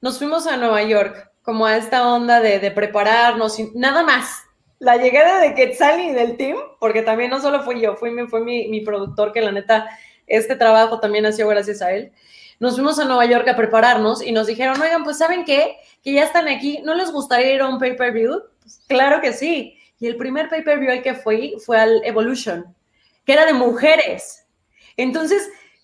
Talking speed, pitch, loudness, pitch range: 205 wpm, 245 Hz, -17 LUFS, 220-285 Hz